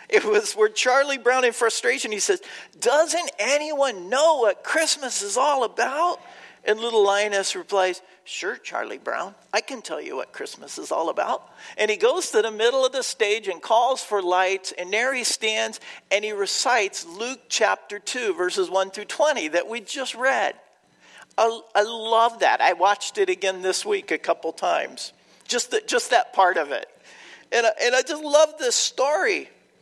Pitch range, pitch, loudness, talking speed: 205-325 Hz, 240 Hz, -22 LUFS, 185 wpm